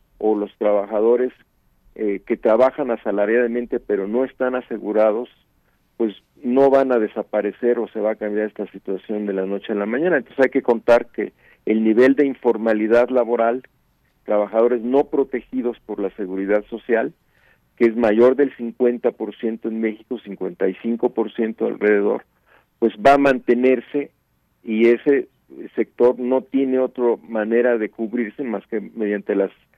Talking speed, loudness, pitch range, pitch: 145 wpm, -20 LUFS, 105-125 Hz, 115 Hz